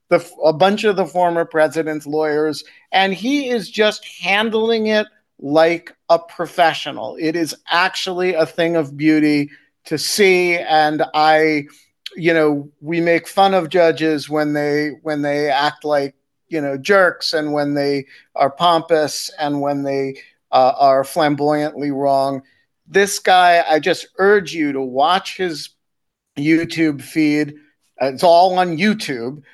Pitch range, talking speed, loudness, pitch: 145-175 Hz, 145 wpm, -17 LUFS, 155 Hz